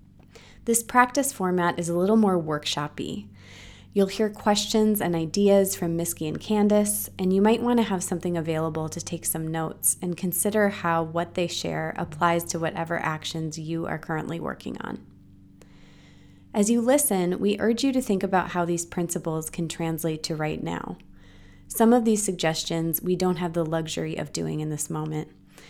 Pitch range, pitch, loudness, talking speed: 160-200 Hz, 170 Hz, -25 LUFS, 175 wpm